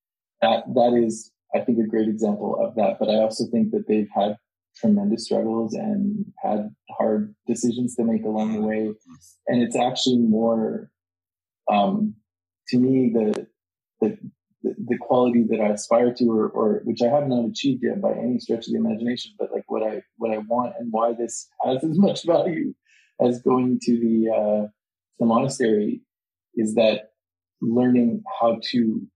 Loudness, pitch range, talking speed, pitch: -23 LUFS, 110-125 Hz, 170 wpm, 115 Hz